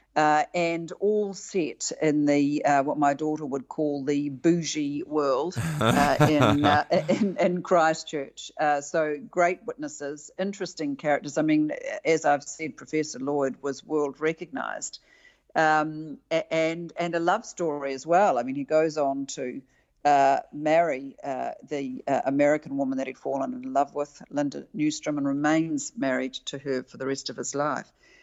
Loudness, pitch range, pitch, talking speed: -26 LUFS, 140-165 Hz, 150 Hz, 160 wpm